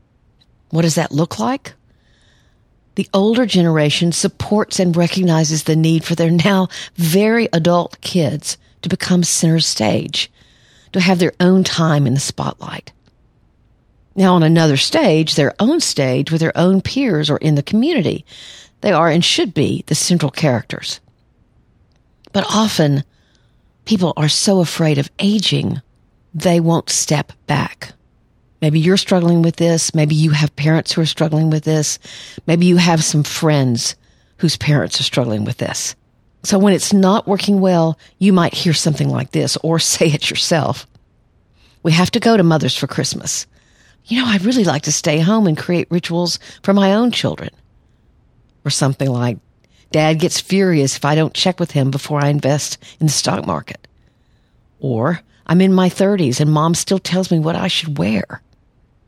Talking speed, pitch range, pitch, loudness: 165 wpm, 145-185 Hz, 165 Hz, -15 LUFS